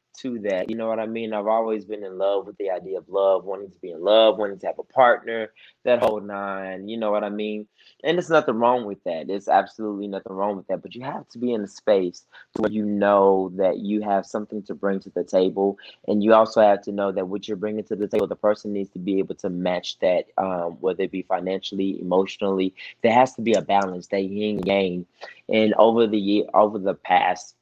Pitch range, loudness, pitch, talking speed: 95-110 Hz, -23 LUFS, 100 Hz, 245 wpm